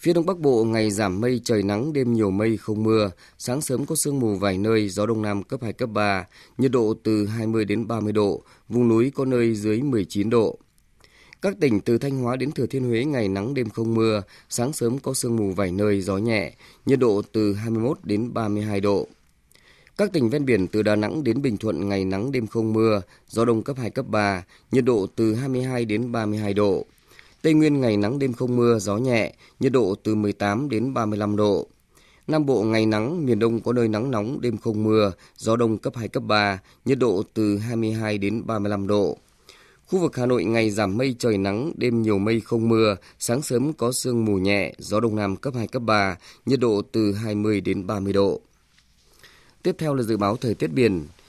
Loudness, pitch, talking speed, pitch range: -23 LUFS, 110 Hz, 215 wpm, 105-120 Hz